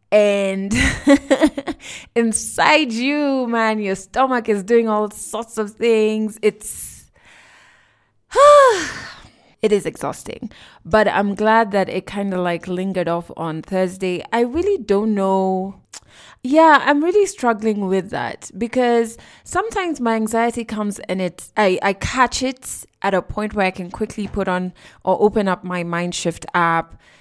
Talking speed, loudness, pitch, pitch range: 140 wpm, -18 LUFS, 215 Hz, 190-235 Hz